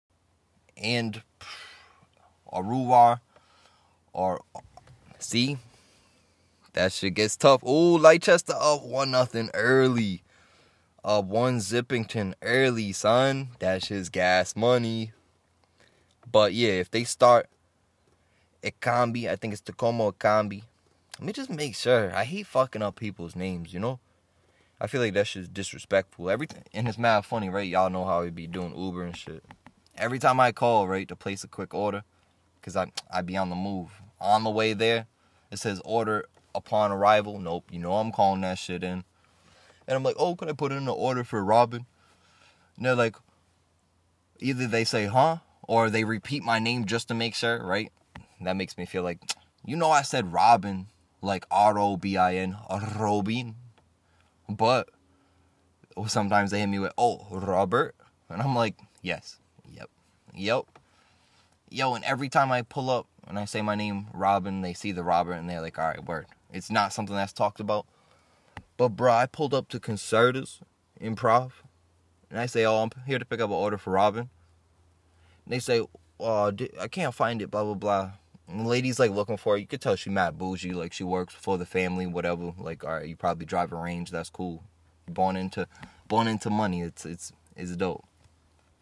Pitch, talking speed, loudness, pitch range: 100 Hz, 180 wpm, -27 LUFS, 90-115 Hz